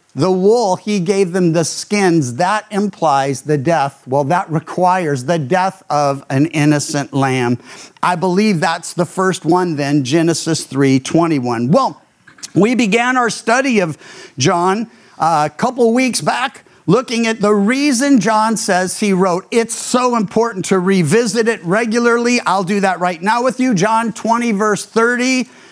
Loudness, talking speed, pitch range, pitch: -15 LUFS, 155 wpm, 165-225 Hz, 190 Hz